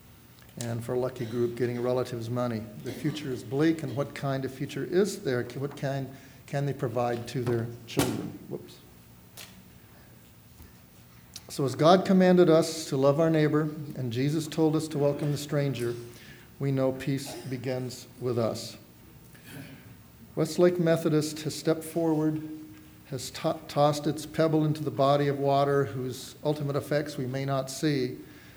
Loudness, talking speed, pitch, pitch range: -28 LUFS, 155 wpm, 135 Hz, 120-150 Hz